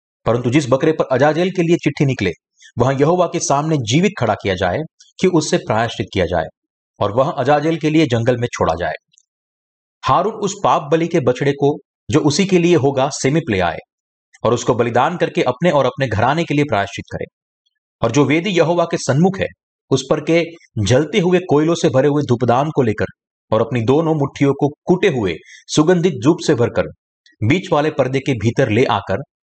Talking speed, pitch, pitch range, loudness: 190 wpm, 145 Hz, 125-170 Hz, -17 LUFS